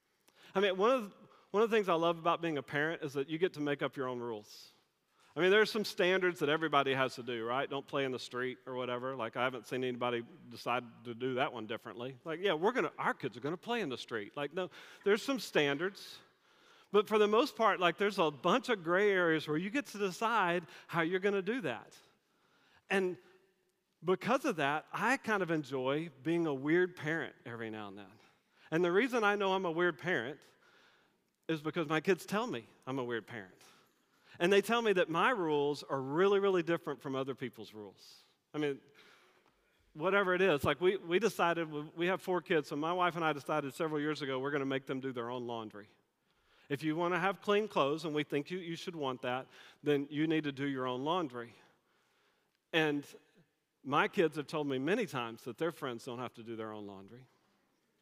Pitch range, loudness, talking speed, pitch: 130-185 Hz, -34 LUFS, 225 wpm, 155 Hz